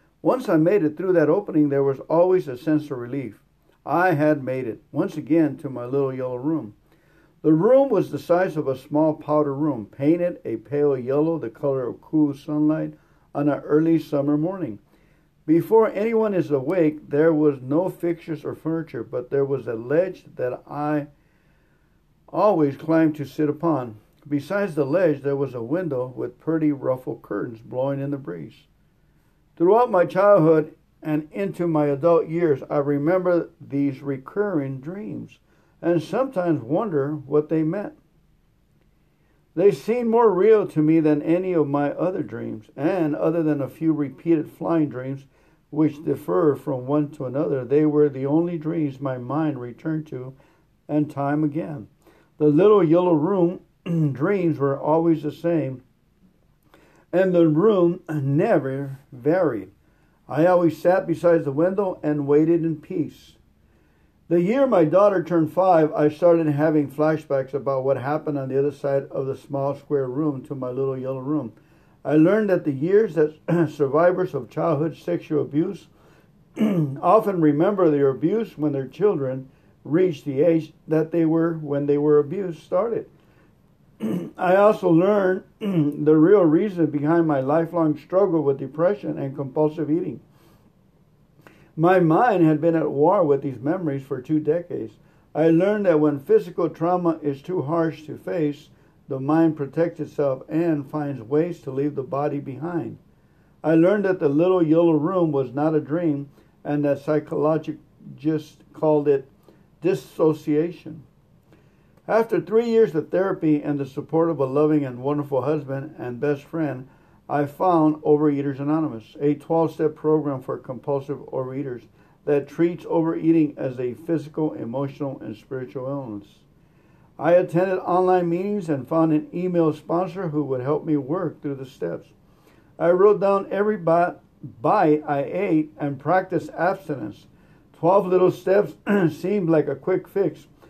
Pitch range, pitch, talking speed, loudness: 145-170 Hz, 155 Hz, 155 wpm, -22 LUFS